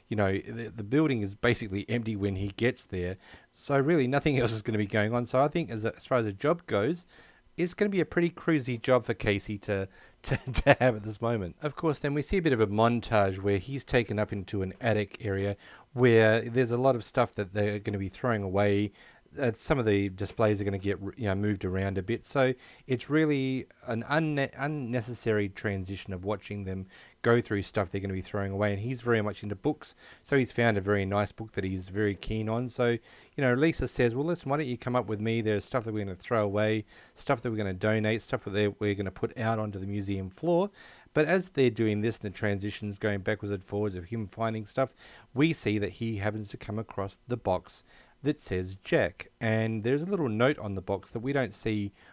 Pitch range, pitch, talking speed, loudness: 100-130 Hz, 110 Hz, 245 wpm, -30 LUFS